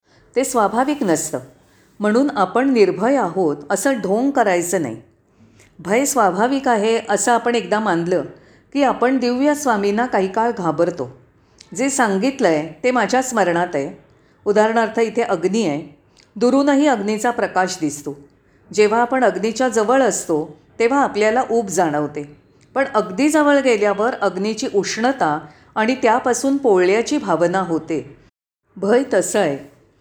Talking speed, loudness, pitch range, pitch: 125 wpm, -18 LUFS, 175-245 Hz, 215 Hz